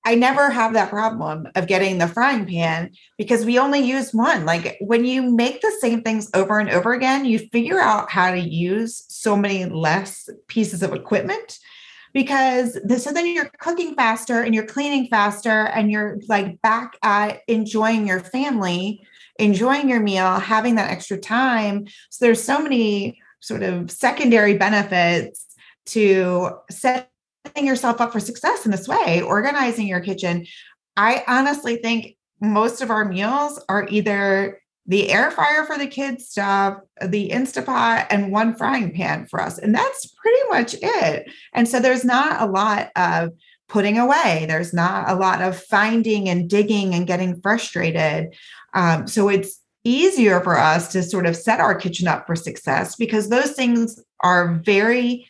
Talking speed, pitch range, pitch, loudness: 165 wpm, 190-245 Hz, 215 Hz, -19 LUFS